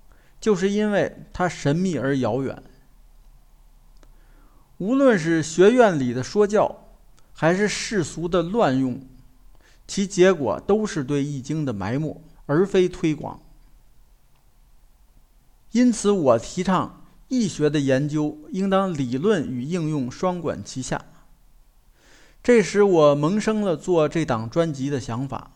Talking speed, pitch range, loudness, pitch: 180 characters per minute, 140-195 Hz, -22 LUFS, 165 Hz